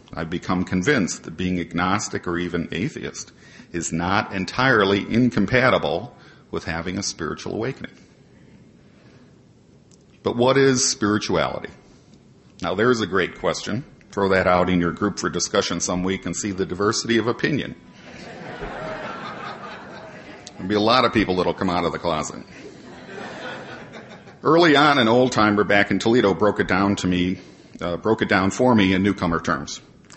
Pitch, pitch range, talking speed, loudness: 95 Hz, 90-105 Hz, 150 wpm, -21 LUFS